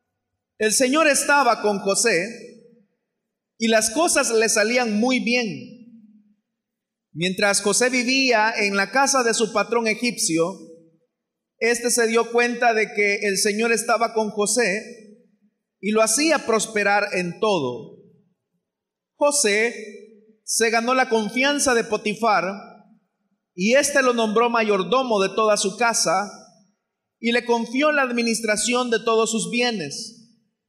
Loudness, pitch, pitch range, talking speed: -20 LUFS, 225 Hz, 210-235 Hz, 125 wpm